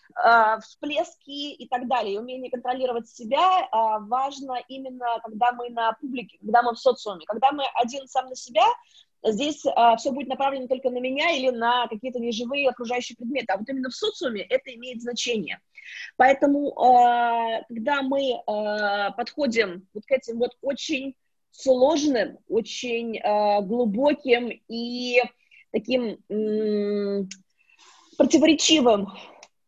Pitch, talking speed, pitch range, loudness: 250 Hz, 120 wpm, 230-275 Hz, -24 LUFS